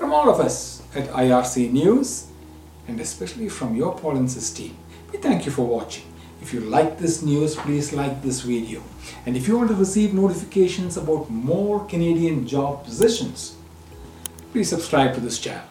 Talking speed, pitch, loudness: 170 wpm, 125 Hz, -22 LUFS